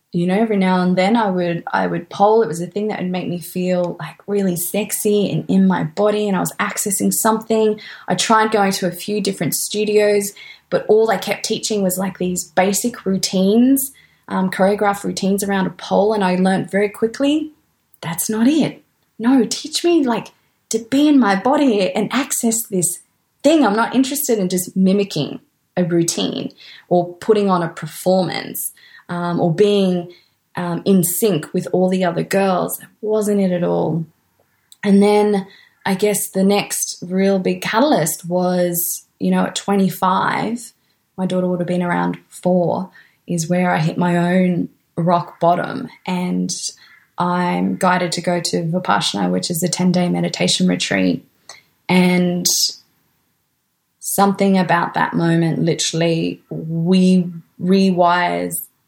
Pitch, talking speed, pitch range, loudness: 185 Hz, 160 wpm, 175-210 Hz, -18 LUFS